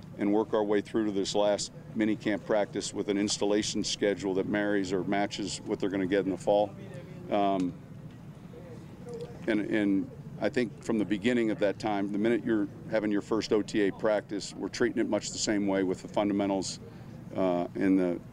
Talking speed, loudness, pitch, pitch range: 195 wpm, -30 LUFS, 105 Hz, 100-115 Hz